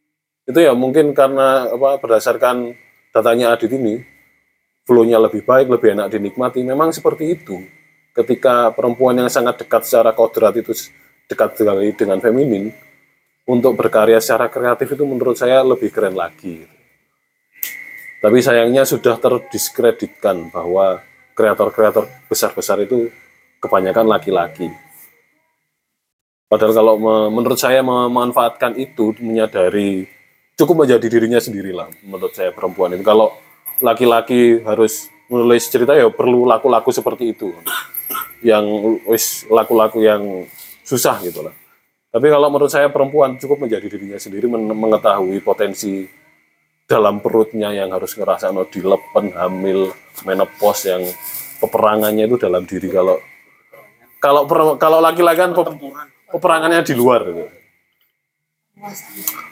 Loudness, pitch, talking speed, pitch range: -15 LUFS, 120 Hz, 120 wpm, 110-150 Hz